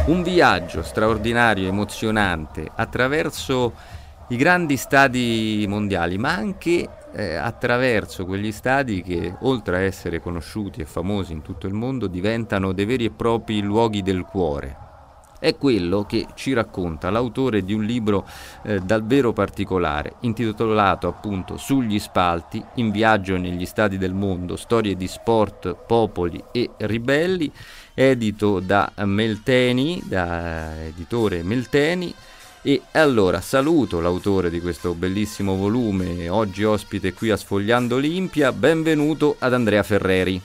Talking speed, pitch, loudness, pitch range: 130 wpm, 105 Hz, -21 LUFS, 90-115 Hz